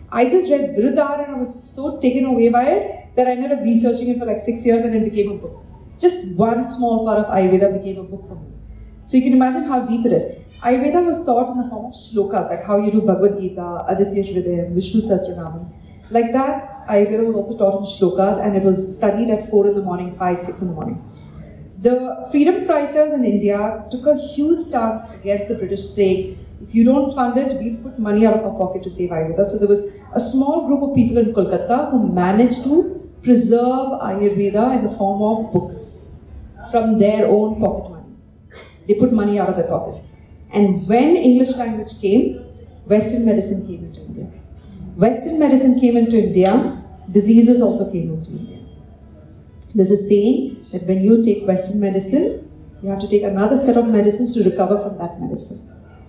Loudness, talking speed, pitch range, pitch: -17 LUFS, 200 wpm, 195-245 Hz, 215 Hz